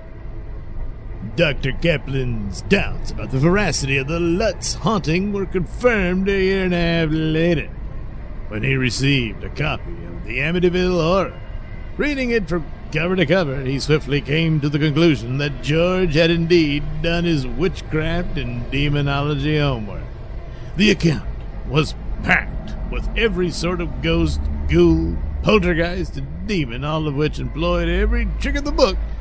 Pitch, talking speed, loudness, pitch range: 155 Hz, 145 wpm, -20 LUFS, 125-175 Hz